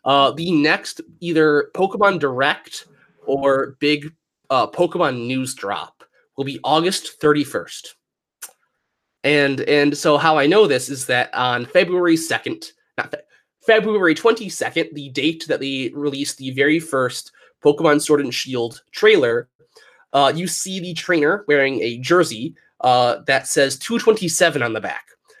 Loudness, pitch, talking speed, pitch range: -18 LUFS, 150 Hz, 140 wpm, 135-175 Hz